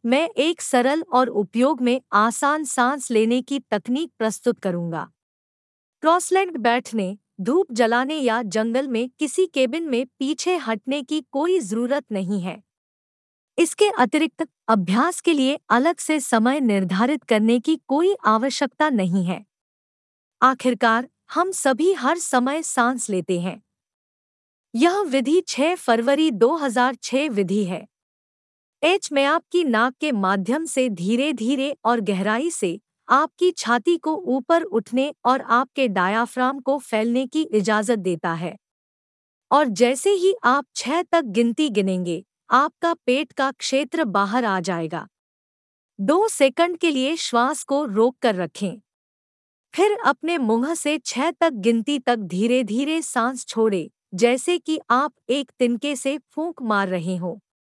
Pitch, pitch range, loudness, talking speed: 255 Hz, 225-305 Hz, -21 LUFS, 135 wpm